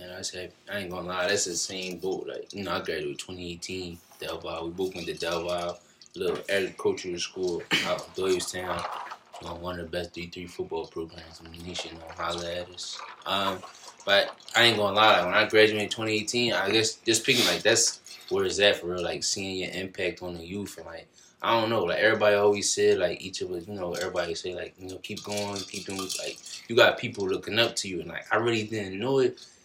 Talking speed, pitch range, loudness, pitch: 235 wpm, 90-115 Hz, -27 LUFS, 100 Hz